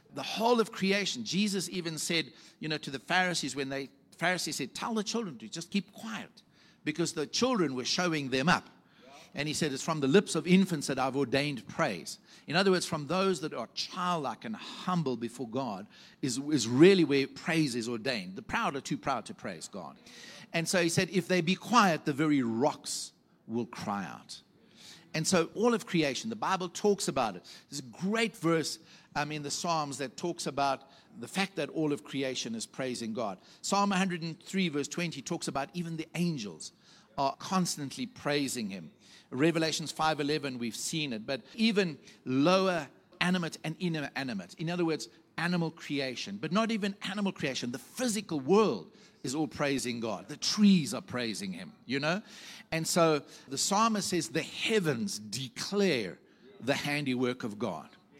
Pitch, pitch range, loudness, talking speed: 165 Hz, 145-195 Hz, -31 LUFS, 185 wpm